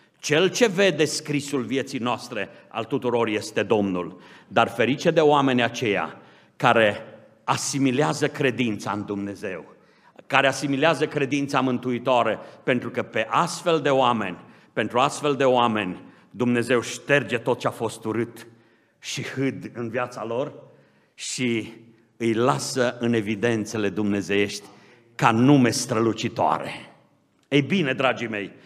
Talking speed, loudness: 125 wpm, -23 LUFS